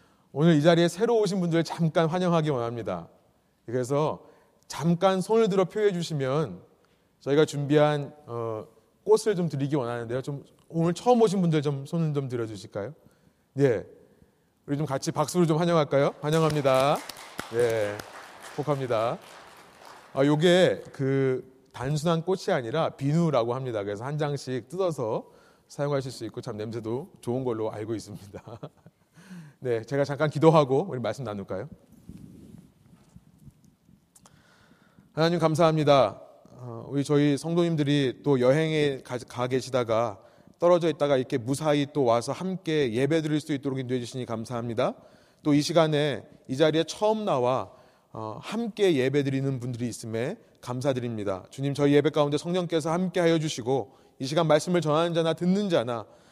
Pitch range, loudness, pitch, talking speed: 130-165 Hz, -26 LUFS, 145 Hz, 315 characters per minute